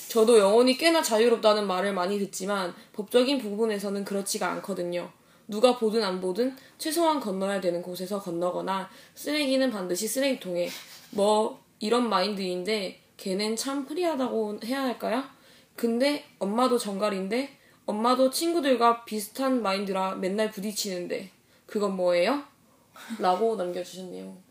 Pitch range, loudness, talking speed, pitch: 190-250 Hz, -27 LUFS, 325 characters per minute, 215 Hz